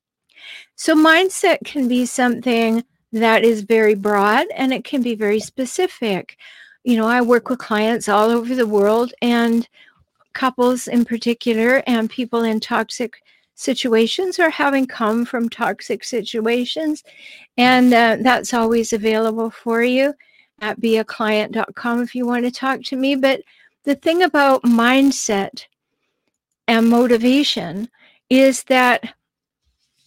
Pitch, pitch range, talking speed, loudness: 240 Hz, 225-265 Hz, 130 wpm, -17 LUFS